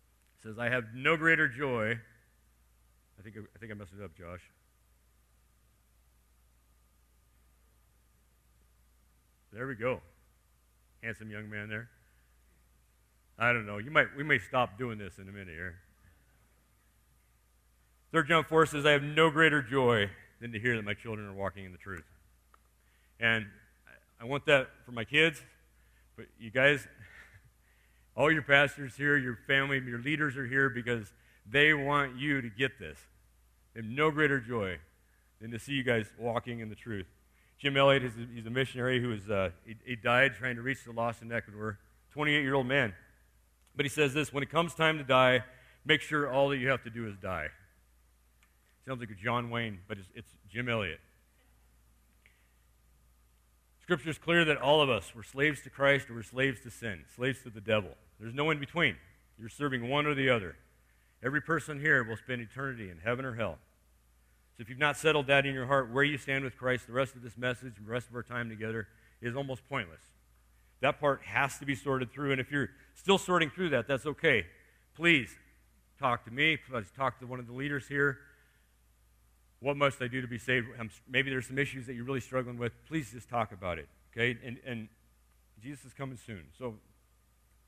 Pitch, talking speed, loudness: 115 Hz, 190 wpm, -31 LUFS